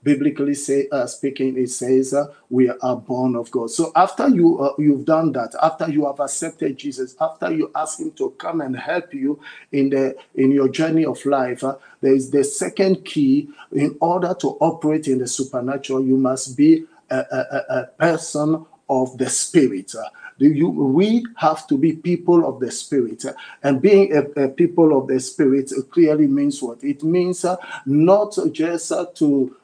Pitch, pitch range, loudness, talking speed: 150 Hz, 135-175 Hz, -19 LUFS, 185 wpm